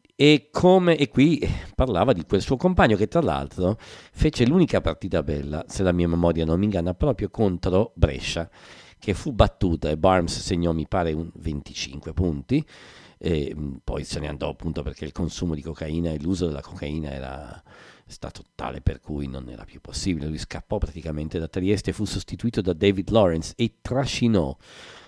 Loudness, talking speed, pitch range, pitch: -24 LUFS, 180 wpm, 75-105 Hz, 85 Hz